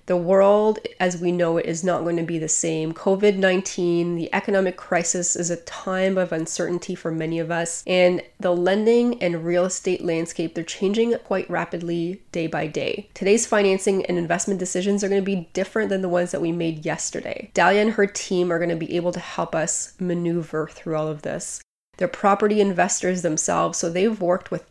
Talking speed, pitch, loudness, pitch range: 200 wpm, 180 Hz, -22 LUFS, 170-195 Hz